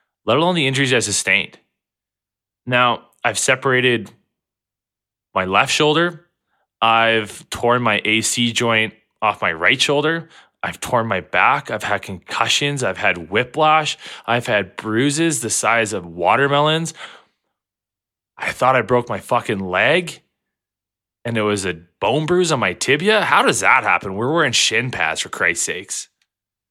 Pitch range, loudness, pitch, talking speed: 100-140 Hz, -17 LUFS, 115 Hz, 145 wpm